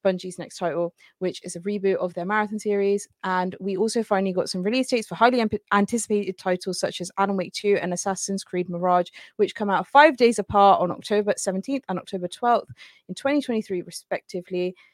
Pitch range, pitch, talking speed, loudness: 180-210 Hz, 195 Hz, 190 wpm, -24 LUFS